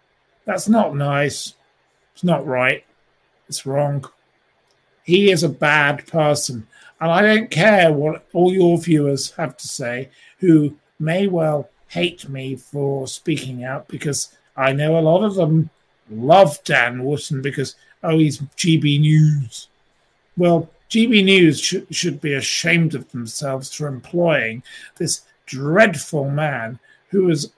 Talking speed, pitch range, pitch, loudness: 135 wpm, 140-170 Hz, 150 Hz, -18 LUFS